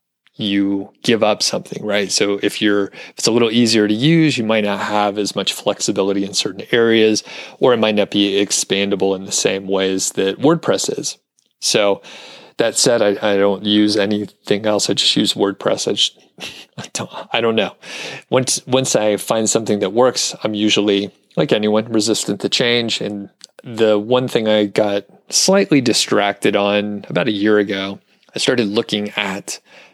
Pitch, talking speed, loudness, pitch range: 105 Hz, 180 wpm, -16 LUFS, 100-110 Hz